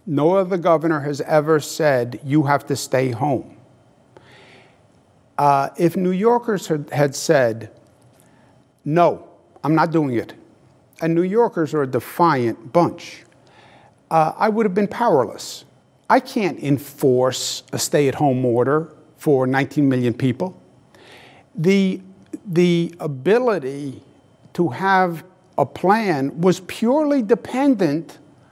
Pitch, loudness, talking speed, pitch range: 155 Hz, -19 LUFS, 120 wpm, 135-180 Hz